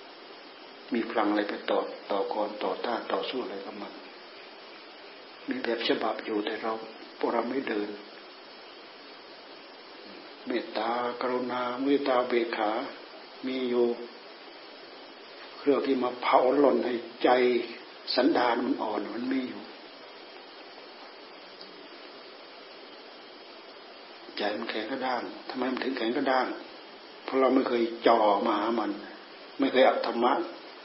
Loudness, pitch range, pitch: -28 LUFS, 120-130 Hz, 125 Hz